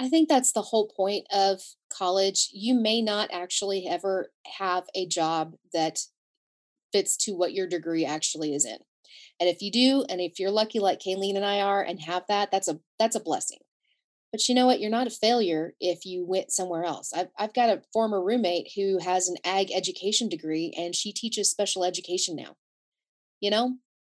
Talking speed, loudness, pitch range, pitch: 195 wpm, -26 LUFS, 180-215 Hz, 195 Hz